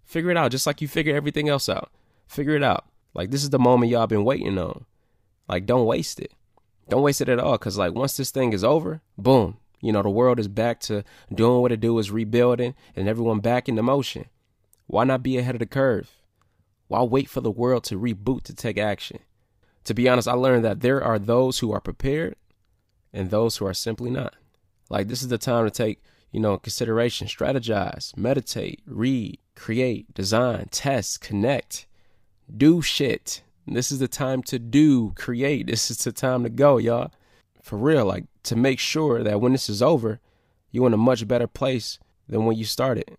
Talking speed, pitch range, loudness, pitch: 205 wpm, 105-130 Hz, -23 LUFS, 120 Hz